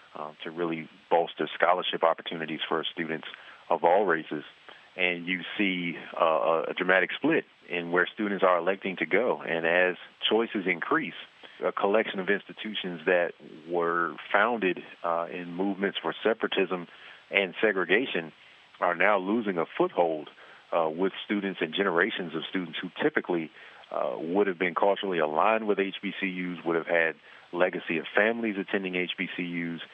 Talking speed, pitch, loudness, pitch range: 145 wpm, 90 Hz, -28 LUFS, 85-100 Hz